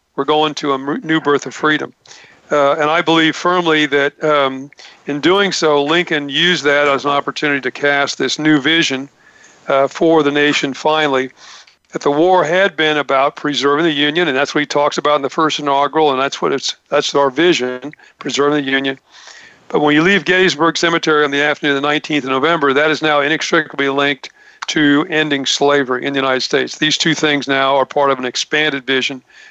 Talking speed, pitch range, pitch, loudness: 200 wpm, 140-155 Hz, 145 Hz, -14 LUFS